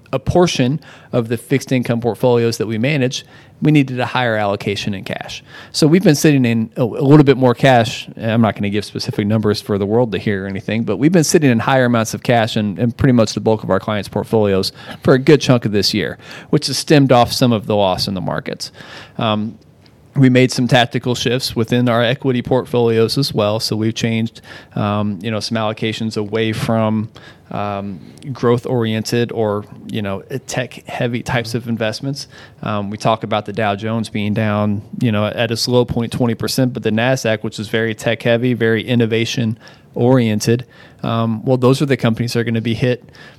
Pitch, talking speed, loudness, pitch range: 115 Hz, 205 wpm, -16 LUFS, 110-130 Hz